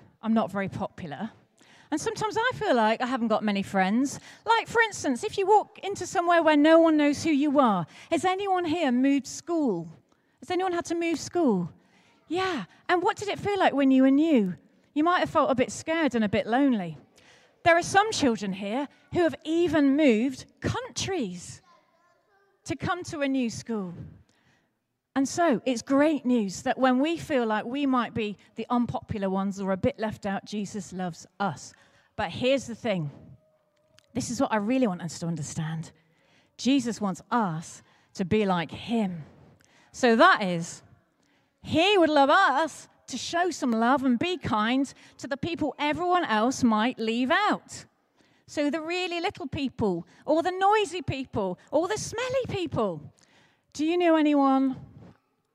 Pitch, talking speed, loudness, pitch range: 265 Hz, 175 wpm, -26 LUFS, 210-335 Hz